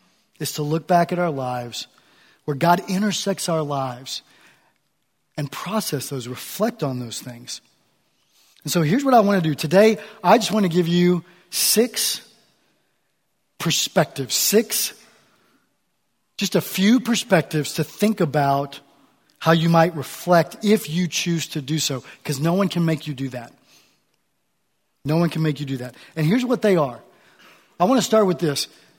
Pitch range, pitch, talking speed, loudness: 145-200 Hz, 165 Hz, 165 wpm, -21 LUFS